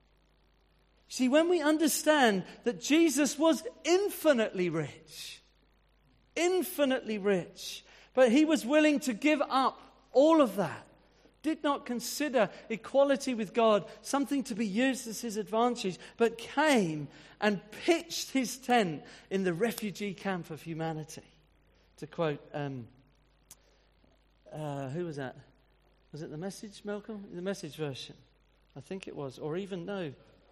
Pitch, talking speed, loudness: 210 Hz, 135 wpm, -30 LUFS